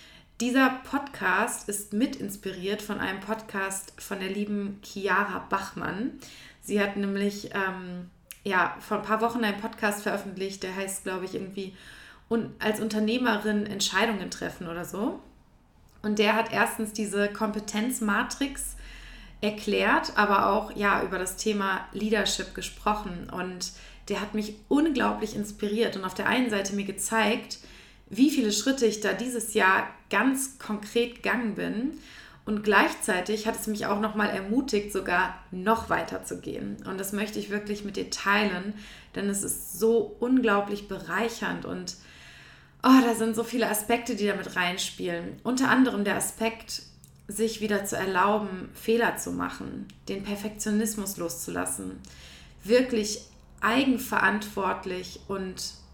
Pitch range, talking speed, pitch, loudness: 195-225 Hz, 140 wpm, 210 Hz, -28 LUFS